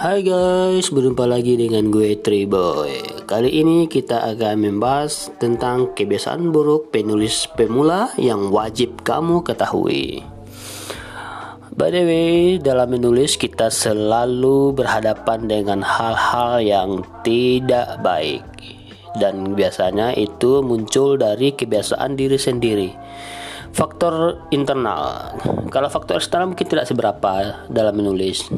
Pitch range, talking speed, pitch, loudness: 110-145 Hz, 110 wpm, 125 Hz, -18 LUFS